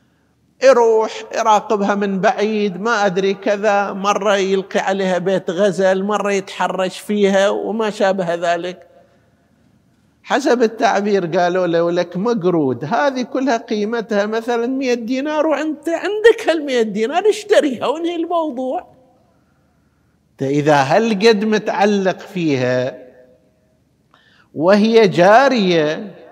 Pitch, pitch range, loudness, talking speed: 205 Hz, 185-235 Hz, -16 LUFS, 100 wpm